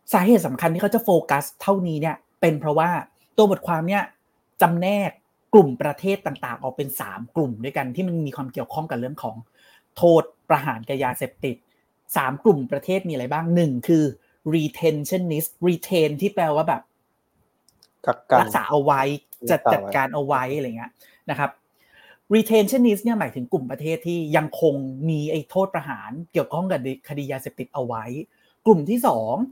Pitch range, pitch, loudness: 140-185 Hz, 160 Hz, -22 LUFS